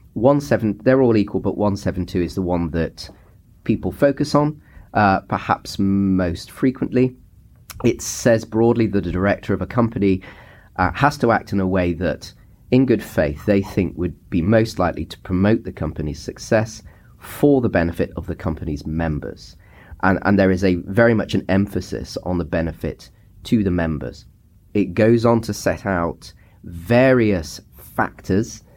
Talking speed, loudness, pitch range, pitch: 165 wpm, -20 LUFS, 90-110 Hz, 100 Hz